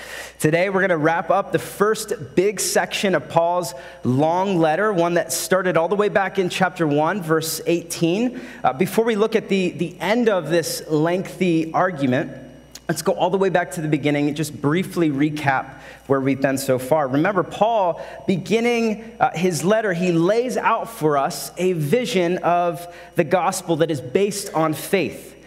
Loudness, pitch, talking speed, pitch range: -20 LUFS, 175 Hz, 180 wpm, 160-195 Hz